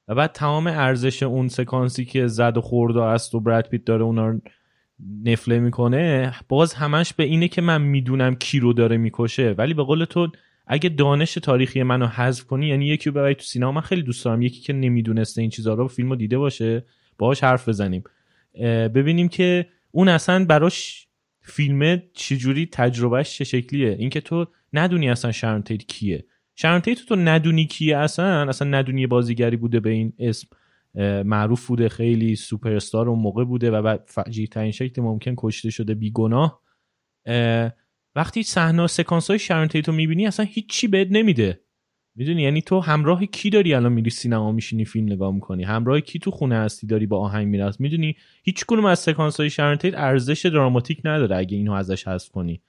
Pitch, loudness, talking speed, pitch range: 130 Hz, -21 LUFS, 165 wpm, 115-160 Hz